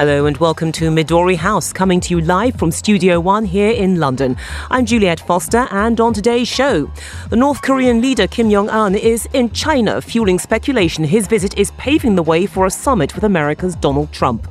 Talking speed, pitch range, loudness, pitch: 200 wpm, 165-230 Hz, -15 LUFS, 195 Hz